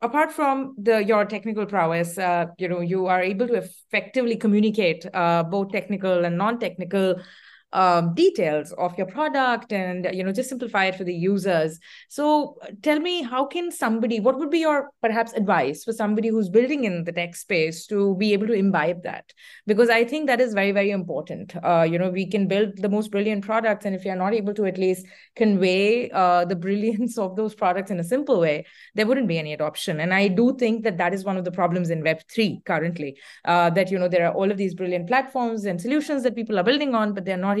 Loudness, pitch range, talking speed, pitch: -23 LUFS, 180-230 Hz, 220 wpm, 200 Hz